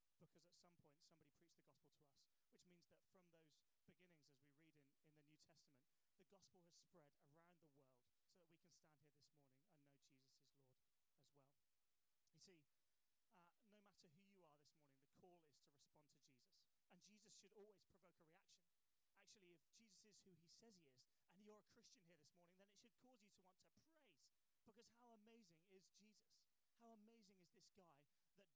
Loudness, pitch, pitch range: -69 LUFS, 170 Hz, 145-195 Hz